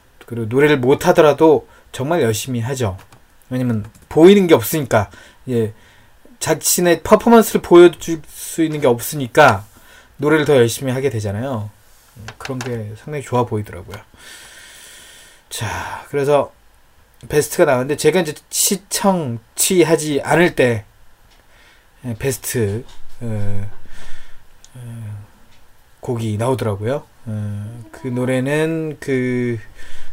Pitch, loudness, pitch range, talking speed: 125 Hz, -16 LUFS, 110-150 Hz, 235 characters per minute